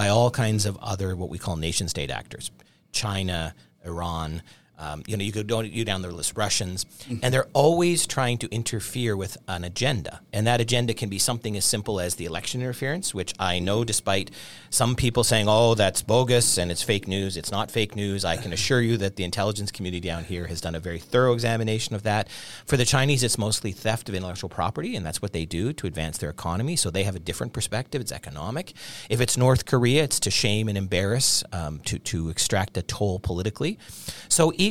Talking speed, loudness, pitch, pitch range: 215 wpm, -25 LUFS, 105 Hz, 90-120 Hz